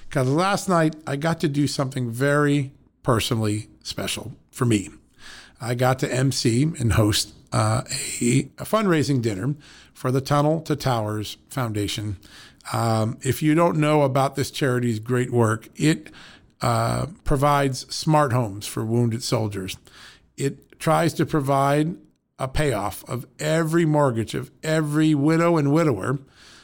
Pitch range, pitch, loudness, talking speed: 120-150 Hz, 135 Hz, -23 LUFS, 140 wpm